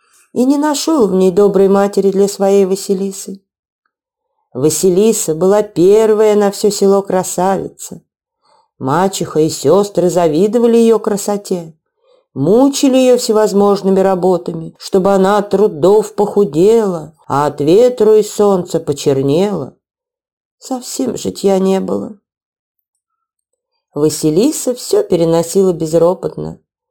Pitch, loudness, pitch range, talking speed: 200 Hz, -12 LUFS, 180-220 Hz, 105 wpm